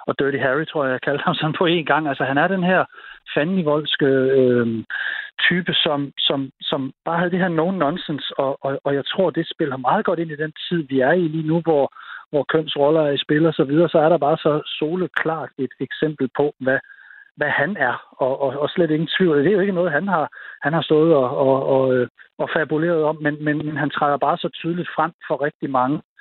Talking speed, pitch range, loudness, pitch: 230 wpm, 140-170 Hz, -20 LUFS, 155 Hz